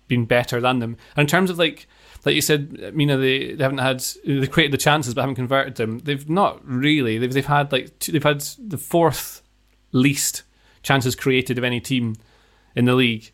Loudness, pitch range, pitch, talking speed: -20 LUFS, 125-145 Hz, 135 Hz, 200 wpm